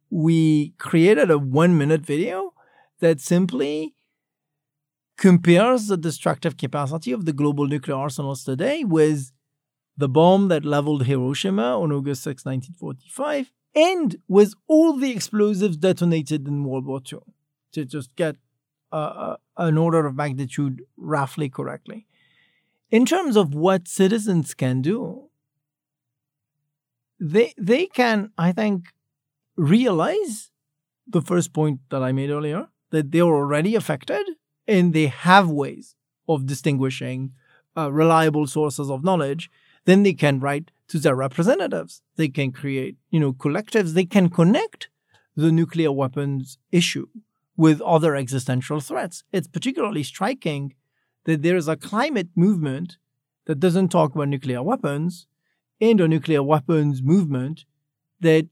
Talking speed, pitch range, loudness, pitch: 130 wpm, 145-180 Hz, -21 LUFS, 155 Hz